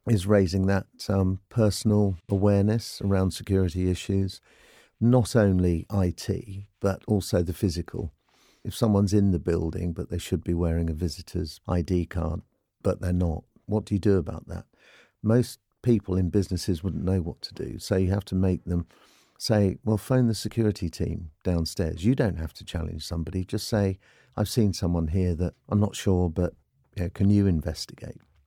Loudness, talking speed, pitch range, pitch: -26 LUFS, 175 wpm, 85-105 Hz, 95 Hz